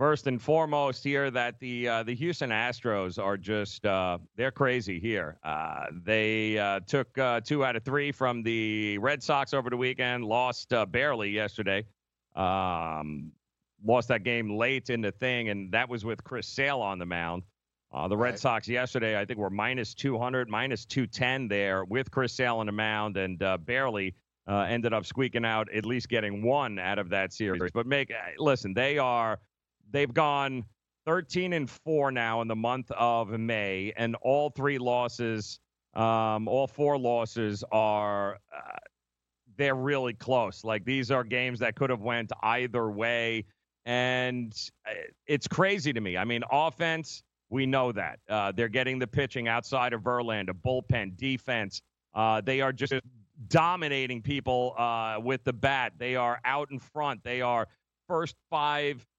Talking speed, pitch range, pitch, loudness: 170 wpm, 105-130 Hz, 120 Hz, -29 LUFS